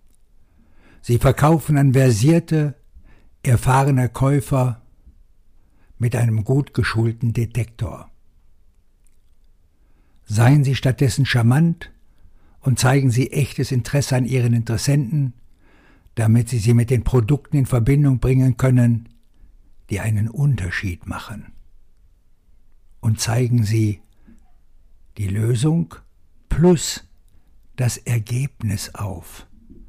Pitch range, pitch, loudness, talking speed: 90-130 Hz, 120 Hz, -19 LUFS, 90 wpm